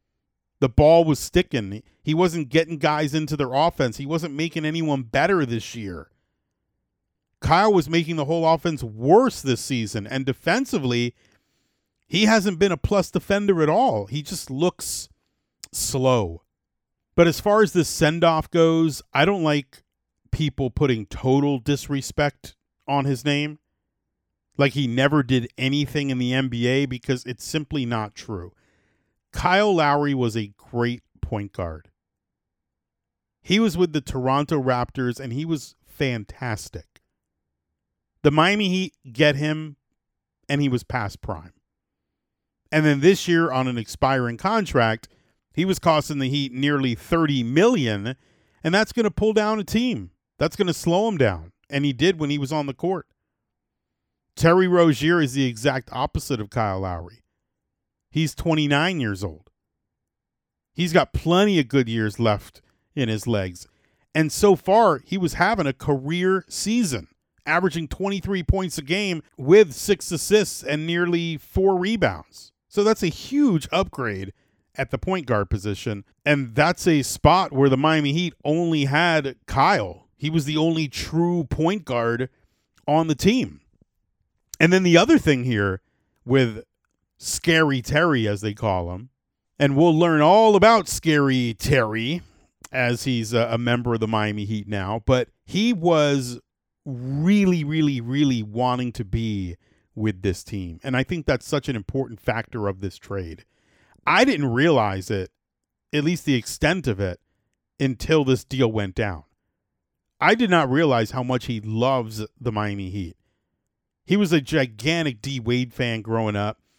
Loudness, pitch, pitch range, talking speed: -22 LUFS, 140 Hz, 115-165 Hz, 155 wpm